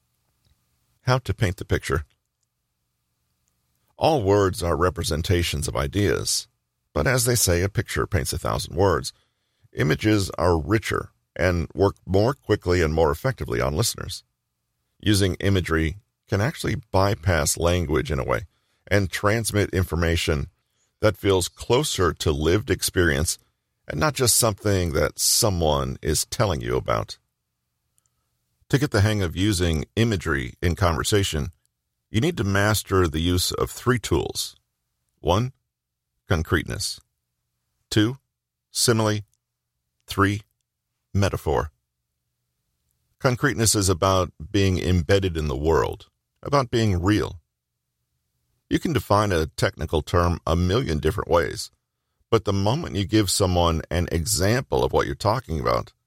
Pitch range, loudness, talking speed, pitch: 75-105 Hz, -23 LUFS, 125 wpm, 90 Hz